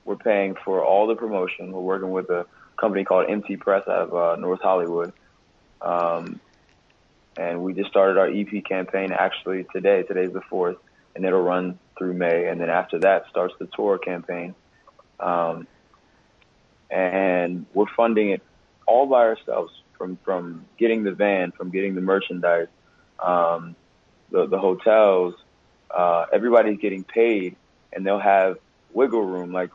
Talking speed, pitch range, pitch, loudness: 155 wpm, 90-95 Hz, 95 Hz, -22 LUFS